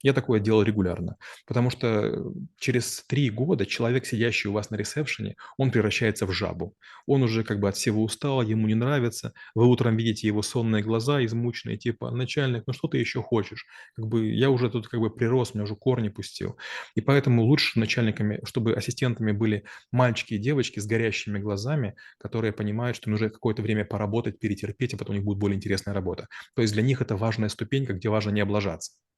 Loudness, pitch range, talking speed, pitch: -26 LUFS, 105-125 Hz, 195 wpm, 115 Hz